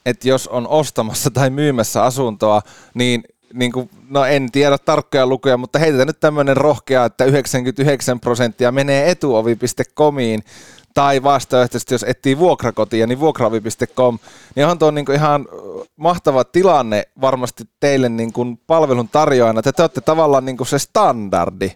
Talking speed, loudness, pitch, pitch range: 145 wpm, -16 LUFS, 130 Hz, 120-145 Hz